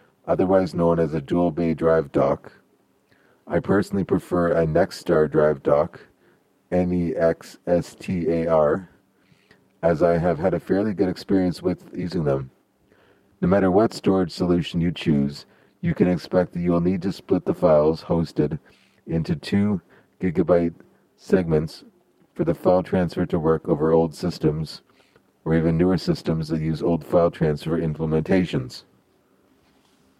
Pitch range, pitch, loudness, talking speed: 80-90 Hz, 85 Hz, -22 LUFS, 150 wpm